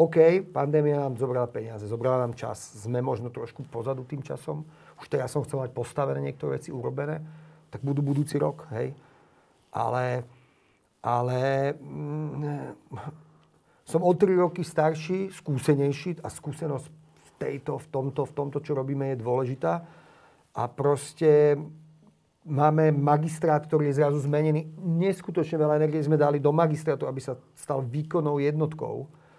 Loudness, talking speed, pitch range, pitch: -27 LUFS, 140 wpm, 135-155 Hz, 145 Hz